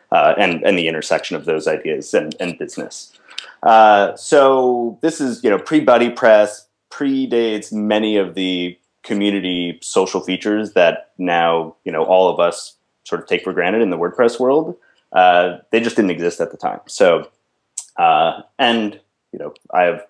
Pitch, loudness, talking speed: 105 Hz, -16 LUFS, 170 wpm